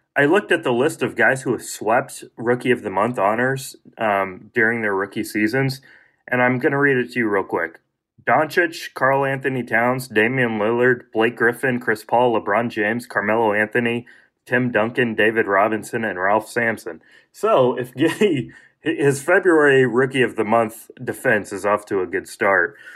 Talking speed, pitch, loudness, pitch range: 175 wpm, 125 Hz, -19 LUFS, 115-135 Hz